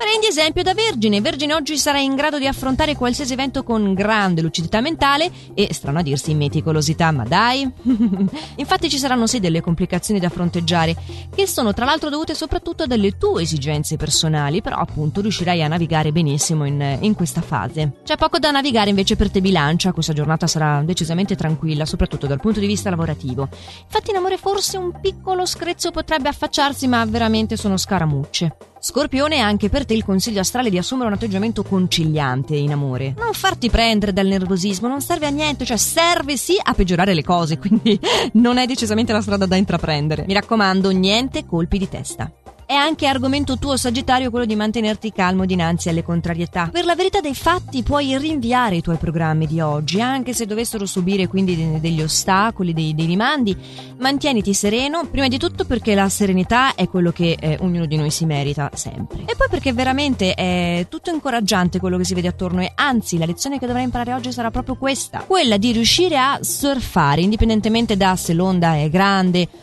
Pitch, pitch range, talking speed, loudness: 205 Hz, 170-270 Hz, 185 wpm, -18 LUFS